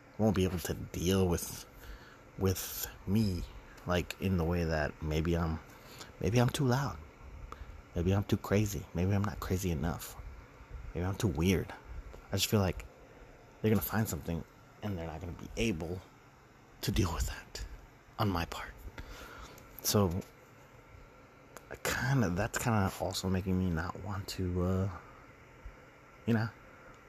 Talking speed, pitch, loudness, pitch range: 155 wpm, 95 Hz, -34 LUFS, 85-105 Hz